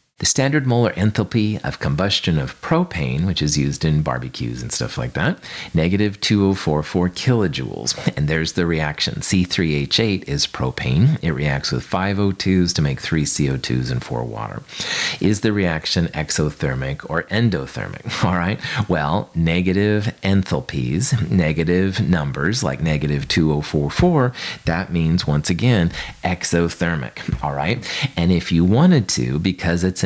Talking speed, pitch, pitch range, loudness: 130 wpm, 85 Hz, 75-100 Hz, -20 LUFS